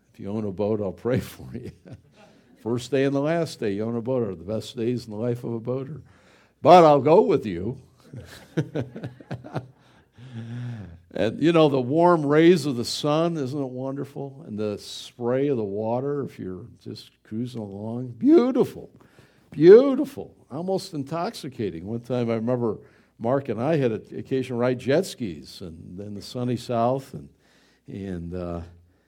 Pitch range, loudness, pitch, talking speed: 110-140 Hz, -23 LUFS, 120 Hz, 170 wpm